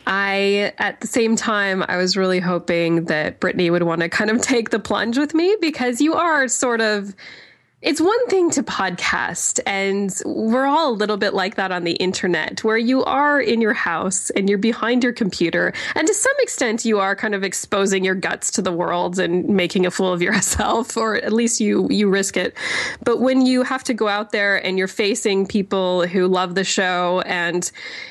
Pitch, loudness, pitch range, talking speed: 205 Hz, -19 LUFS, 185-240 Hz, 205 wpm